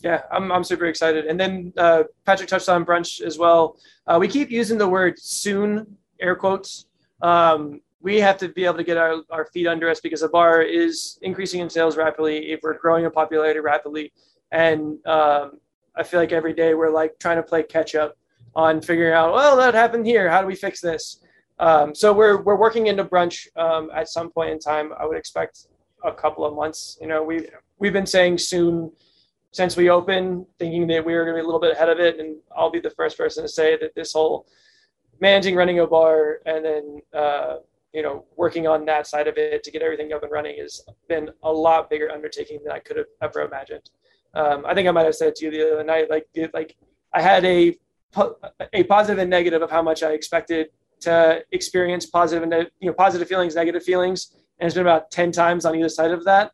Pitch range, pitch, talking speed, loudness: 160-185 Hz, 170 Hz, 225 wpm, -20 LUFS